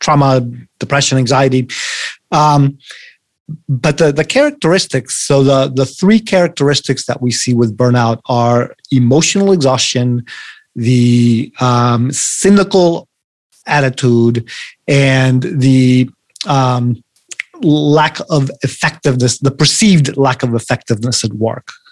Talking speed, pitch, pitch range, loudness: 105 wpm, 135 Hz, 125-150 Hz, -12 LUFS